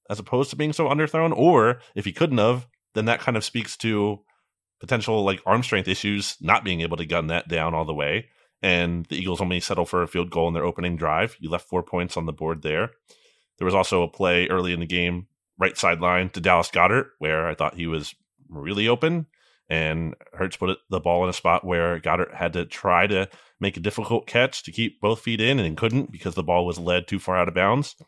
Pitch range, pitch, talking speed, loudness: 85-110 Hz, 90 Hz, 235 wpm, -23 LUFS